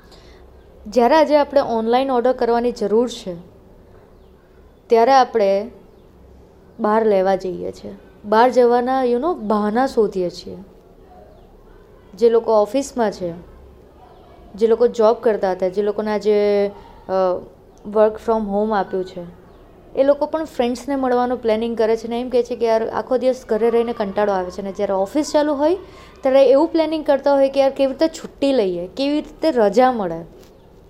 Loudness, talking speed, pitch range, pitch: -18 LUFS, 155 wpm, 200-260 Hz, 230 Hz